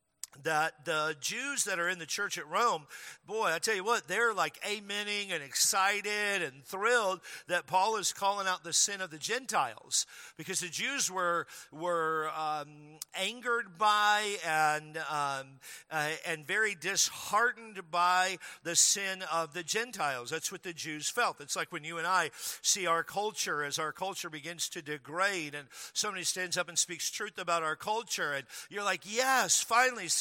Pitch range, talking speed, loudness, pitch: 155-205 Hz, 170 wpm, -31 LUFS, 180 Hz